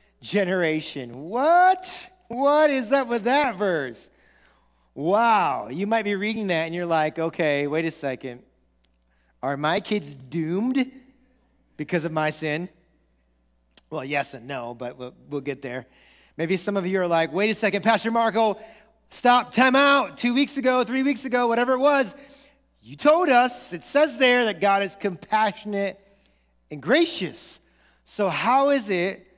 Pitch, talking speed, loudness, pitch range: 200 Hz, 155 wpm, -23 LUFS, 150-250 Hz